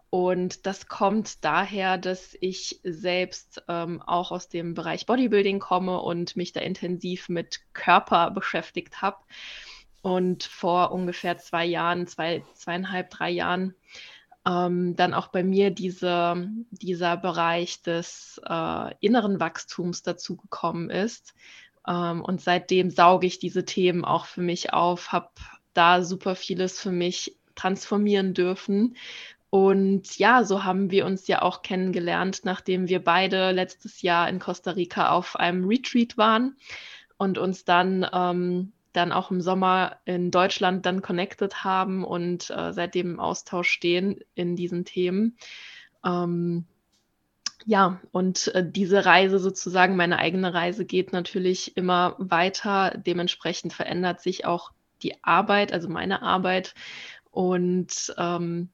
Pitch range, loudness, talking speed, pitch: 175-190 Hz, -25 LUFS, 135 wpm, 180 Hz